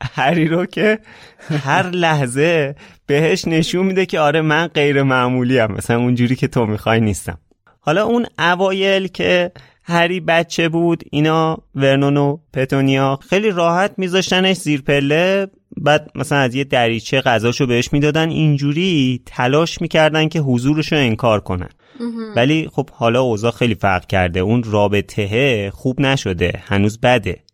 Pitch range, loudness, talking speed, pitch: 125-170 Hz, -16 LUFS, 140 wpm, 145 Hz